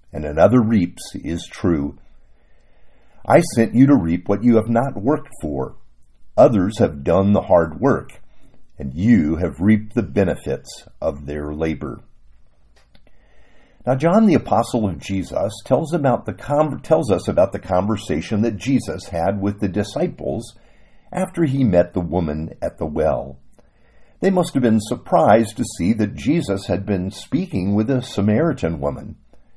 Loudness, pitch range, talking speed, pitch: -19 LUFS, 90-125 Hz, 155 wpm, 105 Hz